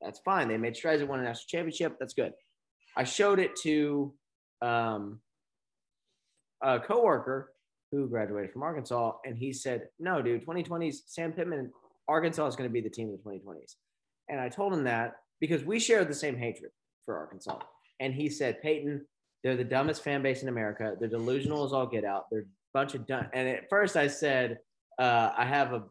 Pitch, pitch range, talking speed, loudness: 135 Hz, 115-155 Hz, 195 wpm, -31 LUFS